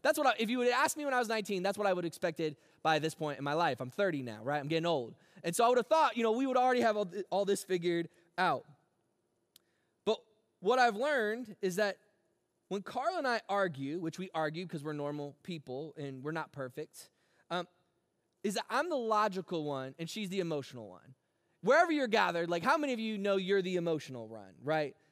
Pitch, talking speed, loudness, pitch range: 180 Hz, 230 wpm, -33 LUFS, 155-220 Hz